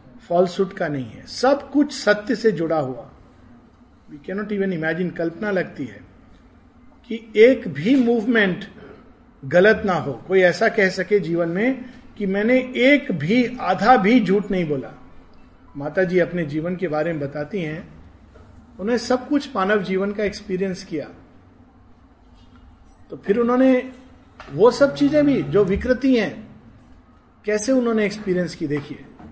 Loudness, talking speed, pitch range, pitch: -20 LUFS, 145 wpm, 155-235 Hz, 195 Hz